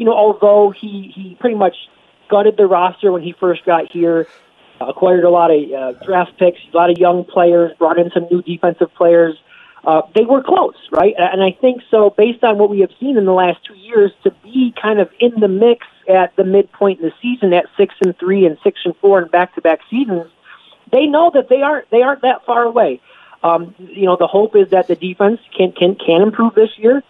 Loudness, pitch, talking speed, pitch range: -13 LUFS, 190 Hz, 225 wpm, 175-220 Hz